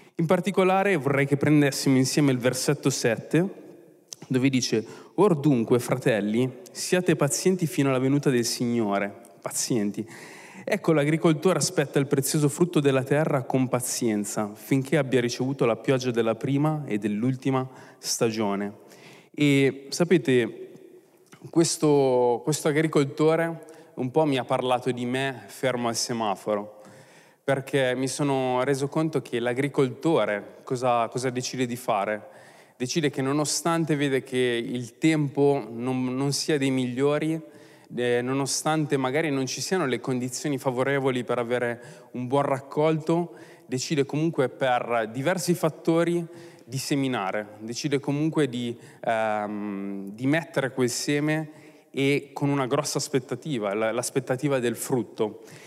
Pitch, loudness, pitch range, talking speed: 135 Hz, -25 LUFS, 125-155 Hz, 130 wpm